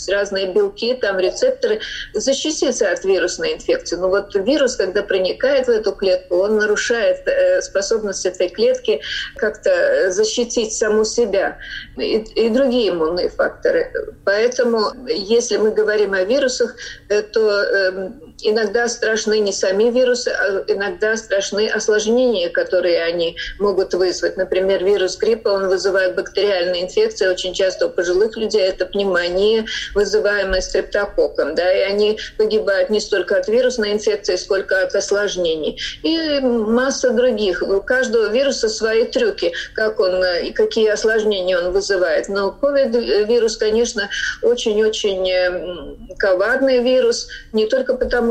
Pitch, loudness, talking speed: 220 Hz, -18 LUFS, 125 wpm